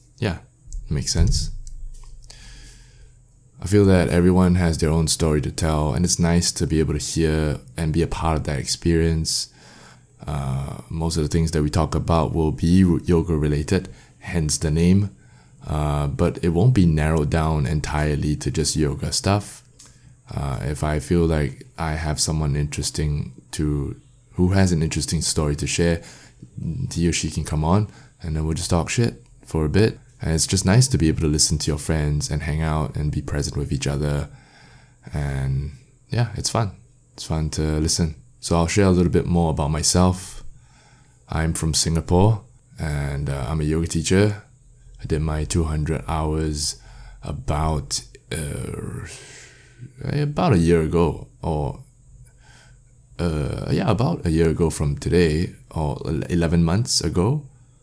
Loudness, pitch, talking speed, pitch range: -22 LUFS, 80 Hz, 165 wpm, 75-105 Hz